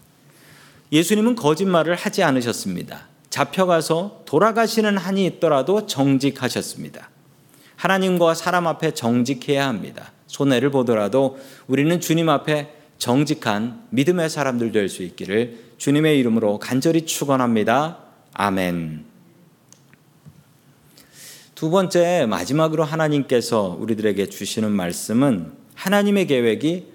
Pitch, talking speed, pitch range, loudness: 150 Hz, 285 characters per minute, 130-170 Hz, -20 LUFS